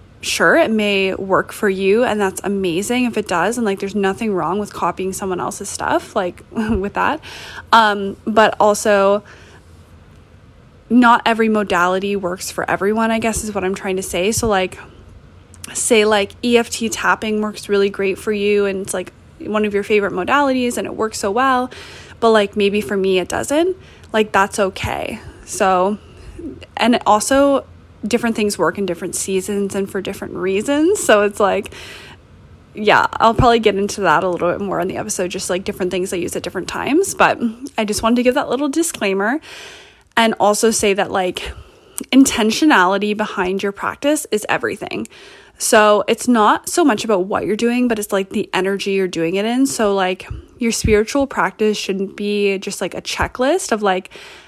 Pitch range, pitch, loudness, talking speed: 190-225 Hz, 205 Hz, -17 LUFS, 185 wpm